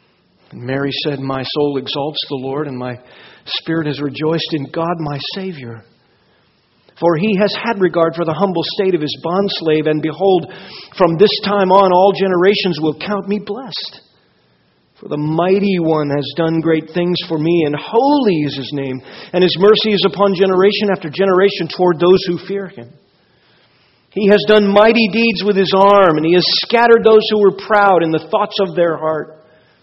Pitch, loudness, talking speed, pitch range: 175 Hz, -14 LUFS, 180 wpm, 155-200 Hz